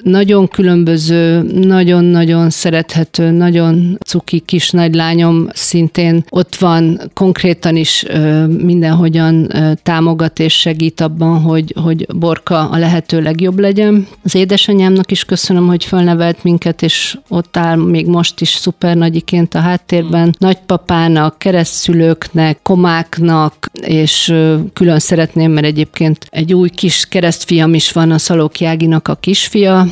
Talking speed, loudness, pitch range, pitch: 125 wpm, -11 LUFS, 165-180 Hz, 170 Hz